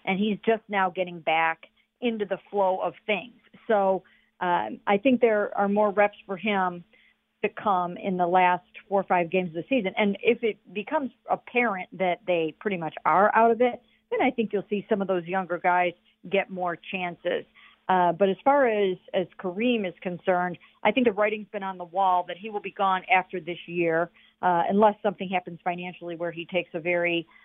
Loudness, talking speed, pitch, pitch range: -26 LUFS, 205 wpm, 190 Hz, 180-210 Hz